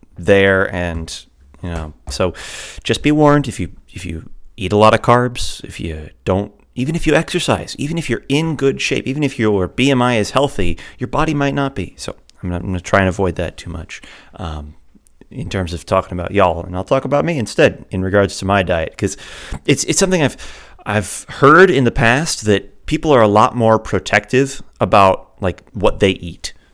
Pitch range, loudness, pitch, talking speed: 90-135 Hz, -16 LUFS, 105 Hz, 205 wpm